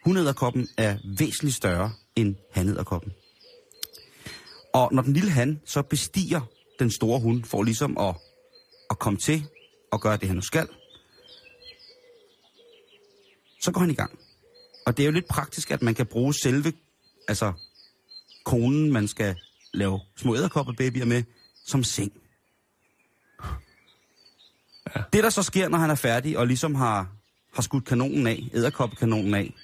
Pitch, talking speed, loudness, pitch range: 130 Hz, 145 wpm, -25 LUFS, 110-175 Hz